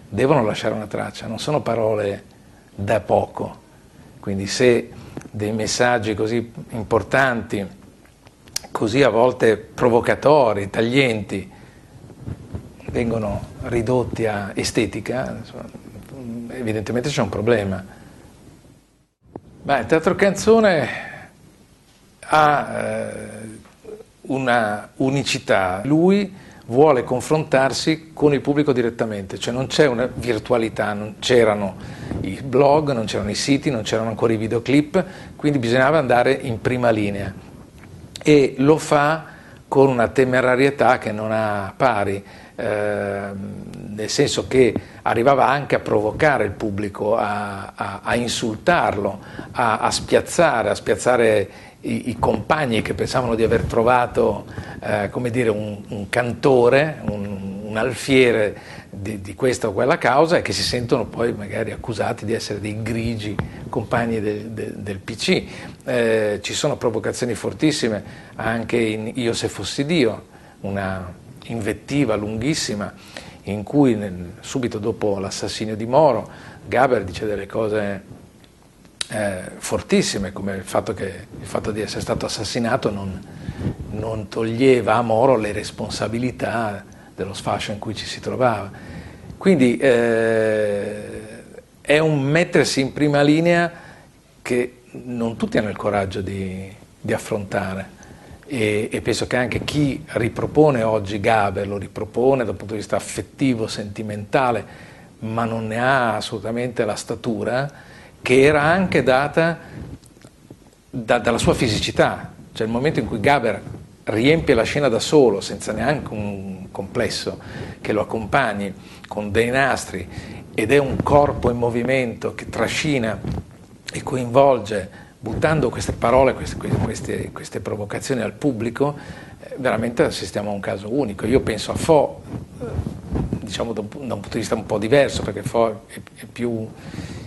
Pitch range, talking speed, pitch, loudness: 105-130 Hz, 130 wpm, 115 Hz, -20 LUFS